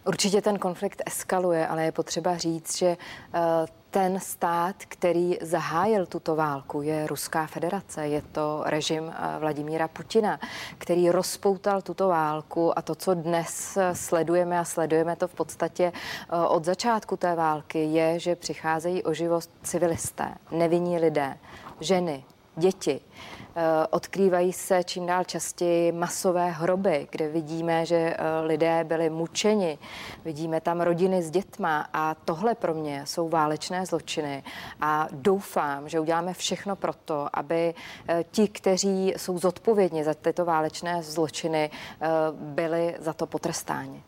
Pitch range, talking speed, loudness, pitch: 160-180 Hz, 130 wpm, -27 LUFS, 170 Hz